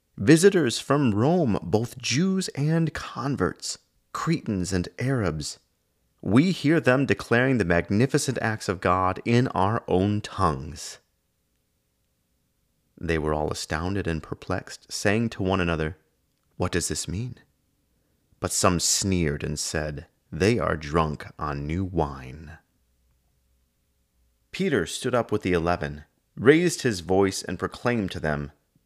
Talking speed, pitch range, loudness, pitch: 125 wpm, 75-115 Hz, -25 LUFS, 90 Hz